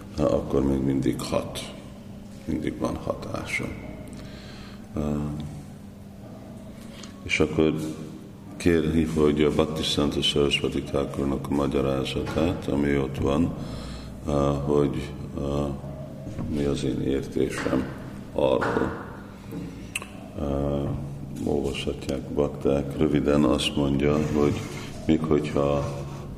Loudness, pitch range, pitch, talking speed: -26 LUFS, 70-75 Hz, 70 Hz, 80 wpm